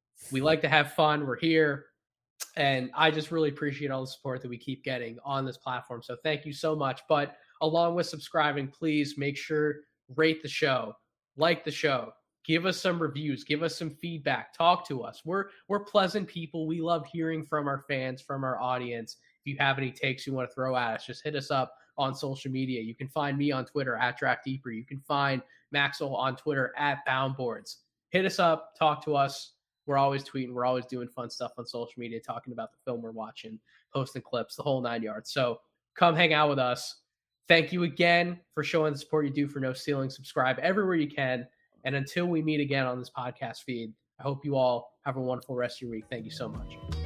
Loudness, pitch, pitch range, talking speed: -30 LUFS, 140 Hz, 130-155 Hz, 220 wpm